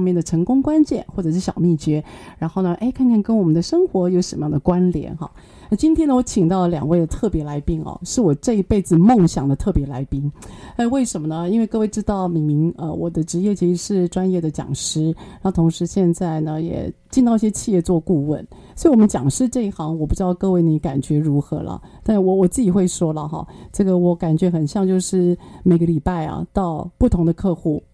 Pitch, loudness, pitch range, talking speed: 175 Hz, -19 LUFS, 160-195 Hz, 330 characters per minute